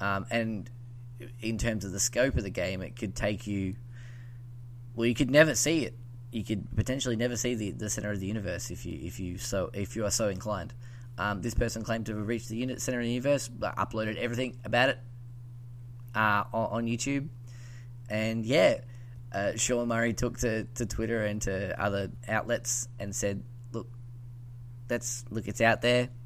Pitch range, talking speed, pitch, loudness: 110-120 Hz, 190 wpm, 120 Hz, -30 LUFS